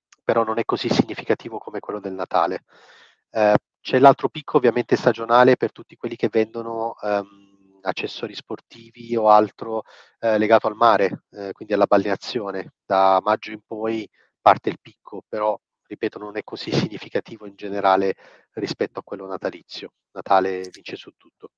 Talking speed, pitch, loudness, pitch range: 155 wpm, 105 Hz, -21 LUFS, 100-115 Hz